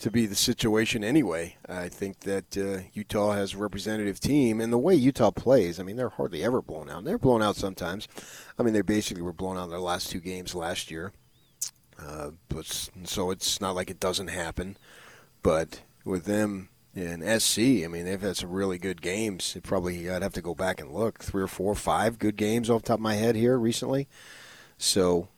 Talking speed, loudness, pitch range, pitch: 220 wpm, -28 LUFS, 90-110 Hz, 100 Hz